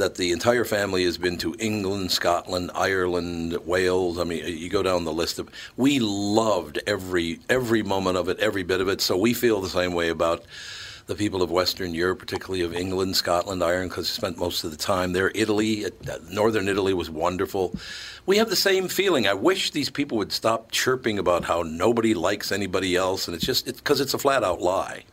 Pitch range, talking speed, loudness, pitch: 90-110 Hz, 210 wpm, -24 LUFS, 95 Hz